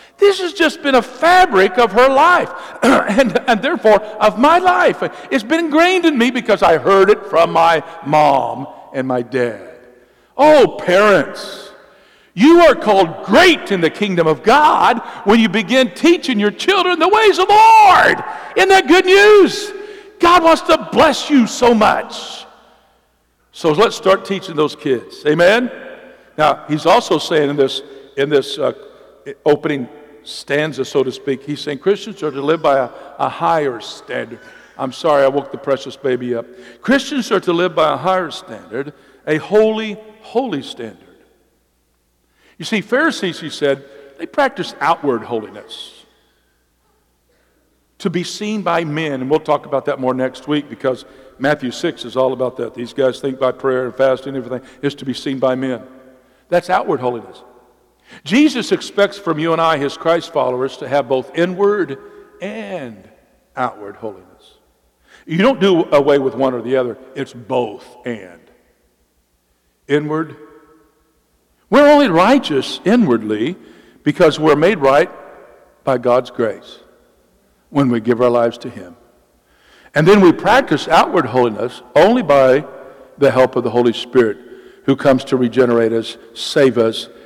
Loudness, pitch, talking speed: -14 LUFS, 155 Hz, 160 wpm